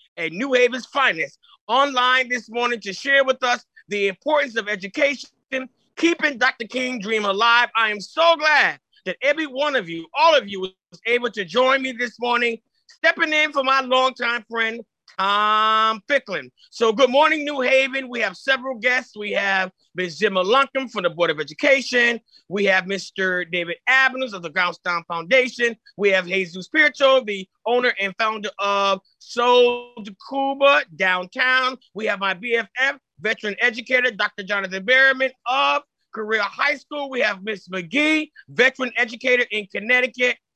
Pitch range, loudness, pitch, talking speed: 200-265 Hz, -20 LUFS, 240 Hz, 165 wpm